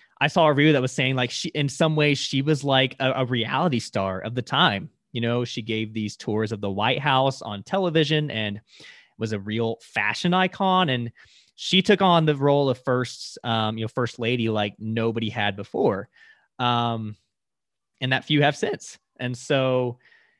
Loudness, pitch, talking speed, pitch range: -23 LUFS, 125 Hz, 190 wpm, 110-145 Hz